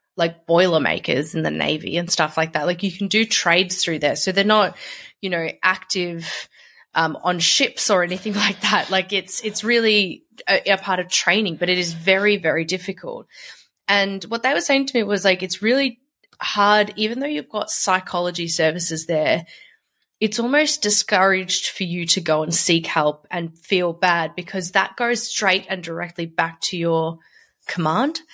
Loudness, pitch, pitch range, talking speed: -19 LUFS, 185 Hz, 170-210 Hz, 180 wpm